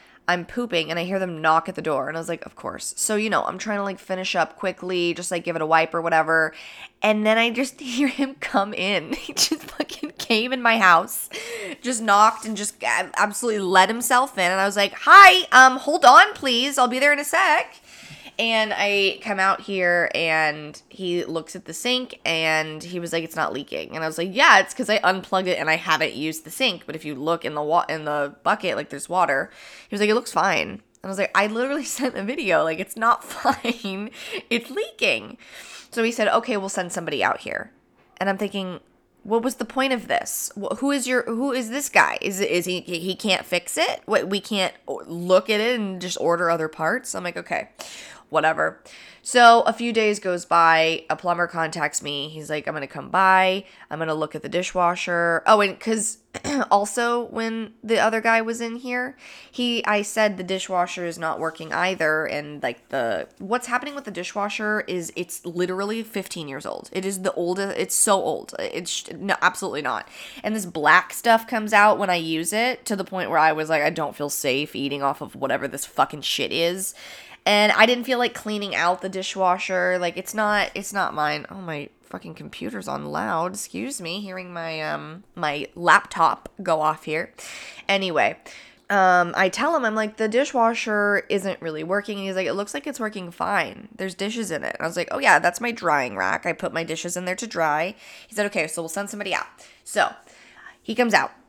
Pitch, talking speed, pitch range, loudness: 195 Hz, 220 wpm, 170-230 Hz, -21 LUFS